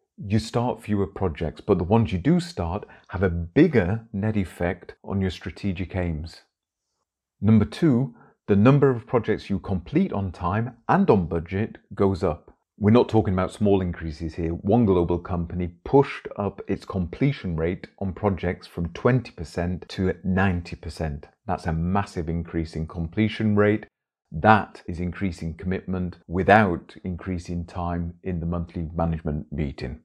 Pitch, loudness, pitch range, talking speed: 95 Hz, -24 LUFS, 85-105 Hz, 150 wpm